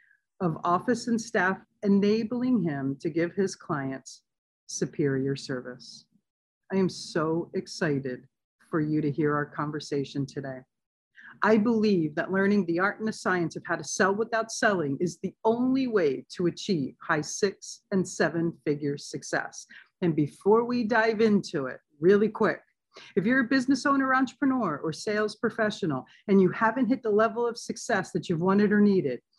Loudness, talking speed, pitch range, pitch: -27 LUFS, 165 wpm, 160-225 Hz, 190 Hz